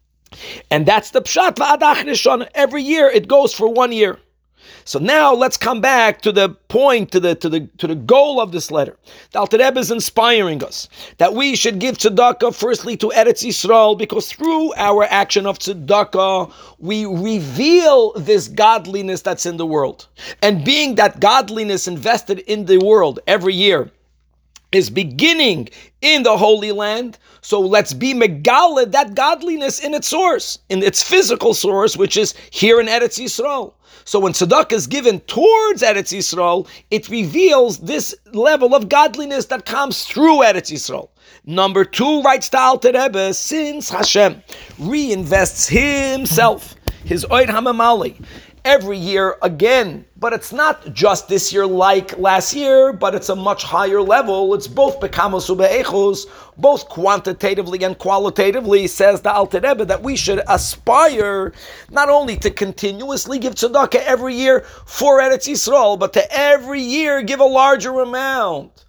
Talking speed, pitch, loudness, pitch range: 150 wpm, 225 Hz, -15 LUFS, 195-275 Hz